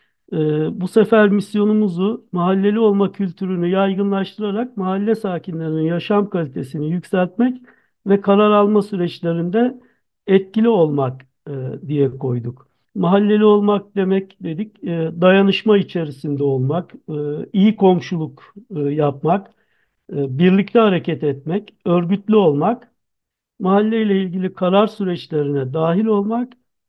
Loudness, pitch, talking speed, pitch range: -18 LUFS, 190 Hz, 95 wpm, 160-210 Hz